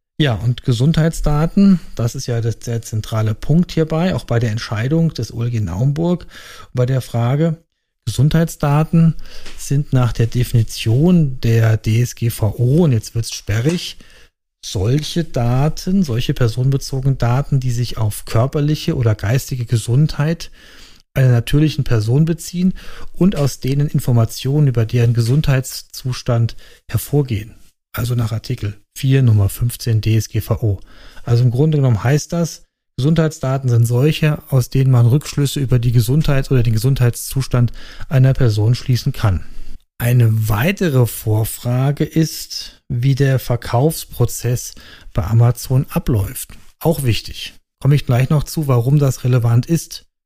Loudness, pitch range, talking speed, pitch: -17 LUFS, 115-150 Hz, 125 wpm, 125 Hz